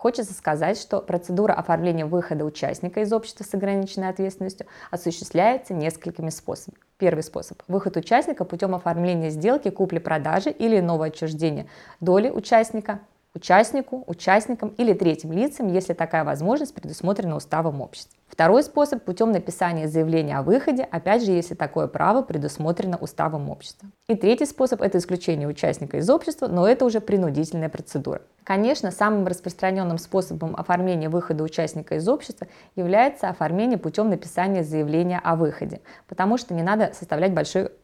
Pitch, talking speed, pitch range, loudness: 185 Hz, 140 wpm, 165-210 Hz, -23 LUFS